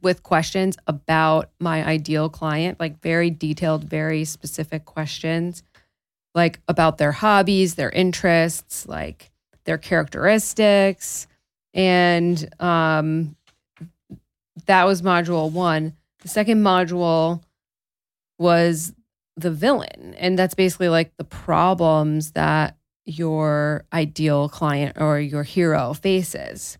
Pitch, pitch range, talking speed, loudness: 165 Hz, 155-180 Hz, 105 wpm, -20 LUFS